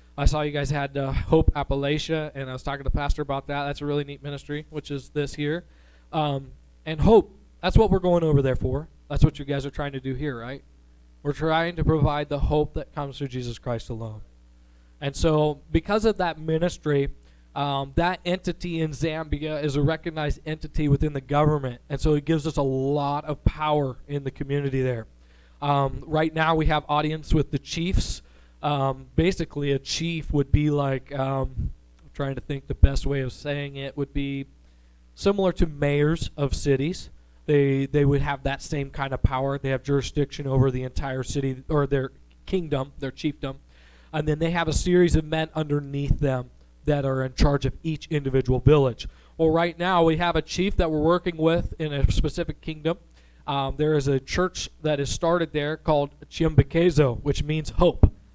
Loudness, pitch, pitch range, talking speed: -25 LUFS, 145 Hz, 135-155 Hz, 195 wpm